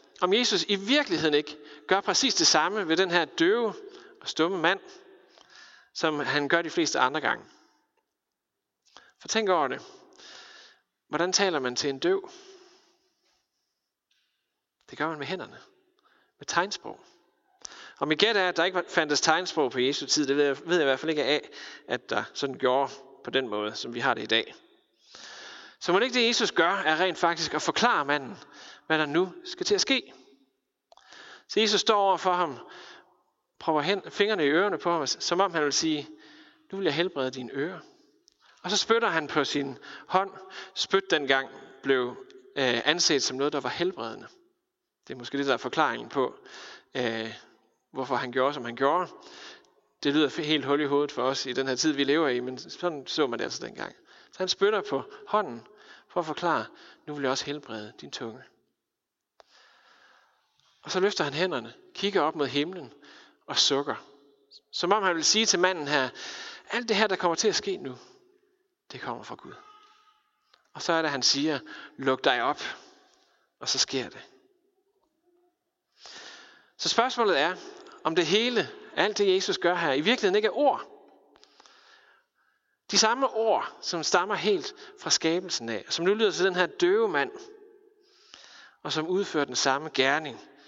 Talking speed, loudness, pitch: 180 wpm, -26 LUFS, 190 Hz